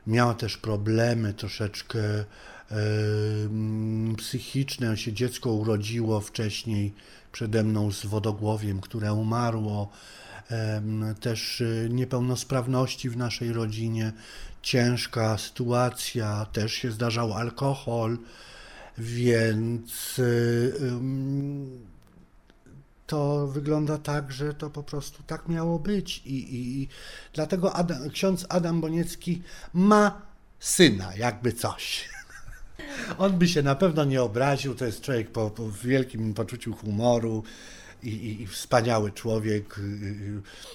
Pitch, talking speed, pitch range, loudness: 120 Hz, 110 wpm, 110-135 Hz, -27 LUFS